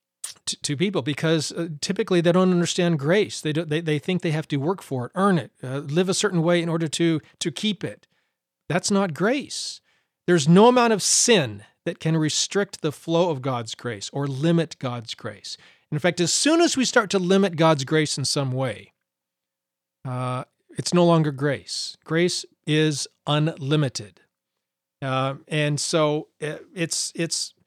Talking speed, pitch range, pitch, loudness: 175 wpm, 140-175 Hz, 160 Hz, -23 LUFS